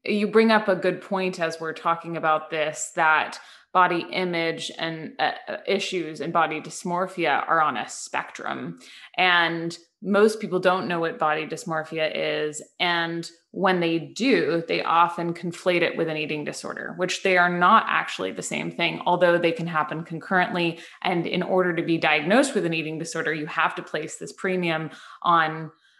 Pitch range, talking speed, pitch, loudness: 160-180 Hz, 175 wpm, 170 Hz, -24 LUFS